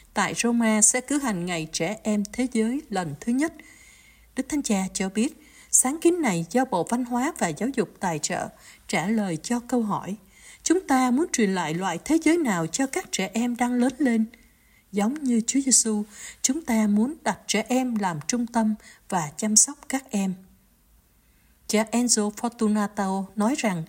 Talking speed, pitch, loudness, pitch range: 185 wpm, 225 Hz, -24 LUFS, 200-255 Hz